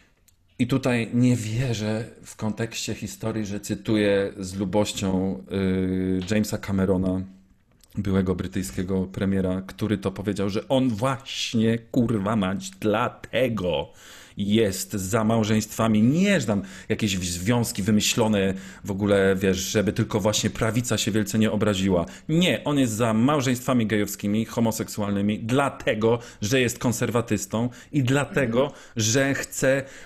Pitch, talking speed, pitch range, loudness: 110 Hz, 120 wpm, 95-120 Hz, -24 LUFS